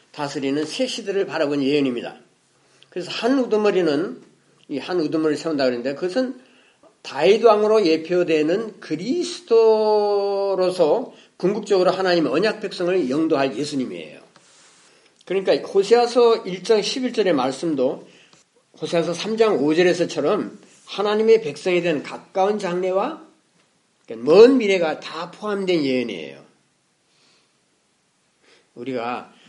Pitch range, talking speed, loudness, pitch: 160-220 Hz, 280 characters per minute, -20 LUFS, 185 Hz